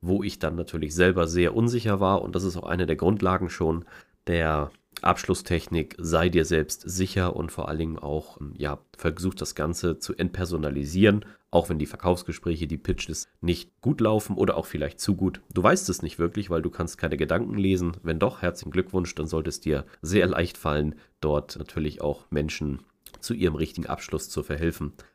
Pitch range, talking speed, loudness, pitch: 80-95 Hz, 190 wpm, -27 LUFS, 85 Hz